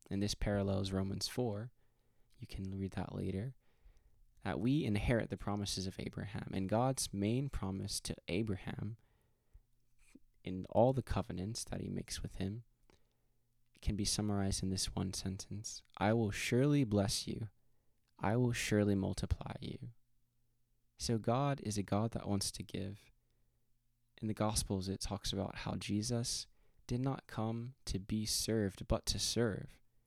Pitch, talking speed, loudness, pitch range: 110 Hz, 150 wpm, -38 LUFS, 100-120 Hz